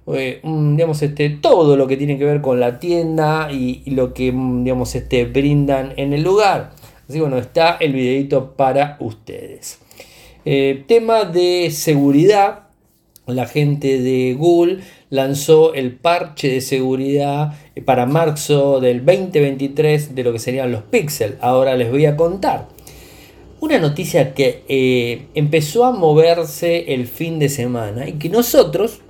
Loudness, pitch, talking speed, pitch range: -16 LUFS, 145 Hz, 145 wpm, 130-160 Hz